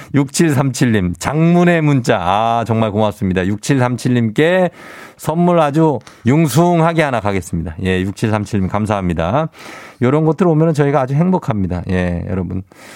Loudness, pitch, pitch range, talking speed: -15 LUFS, 125 Hz, 100-160 Hz, 270 characters per minute